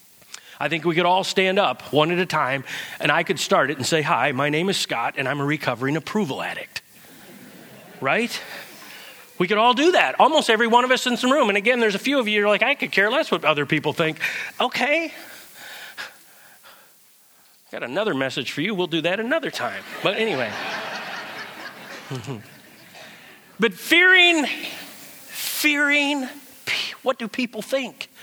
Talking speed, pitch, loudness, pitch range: 170 wpm, 215 Hz, -20 LUFS, 165-270 Hz